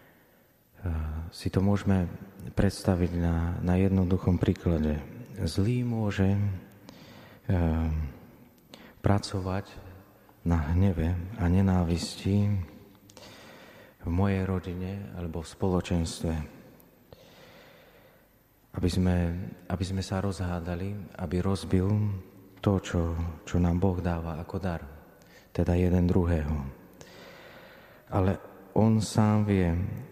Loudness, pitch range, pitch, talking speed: -29 LUFS, 85-100 Hz, 95 Hz, 90 wpm